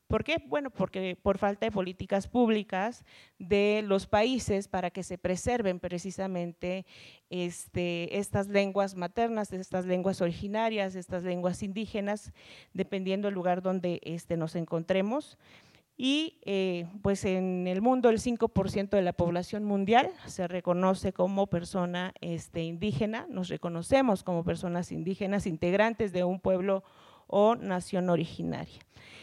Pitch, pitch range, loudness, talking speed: 190 Hz, 180-205 Hz, -30 LUFS, 130 wpm